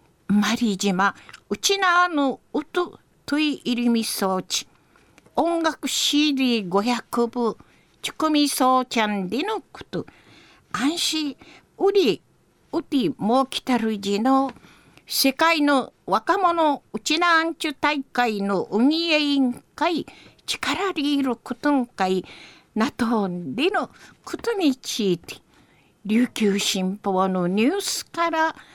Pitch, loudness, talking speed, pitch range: 265 Hz, -22 LUFS, 205 characters per minute, 220-315 Hz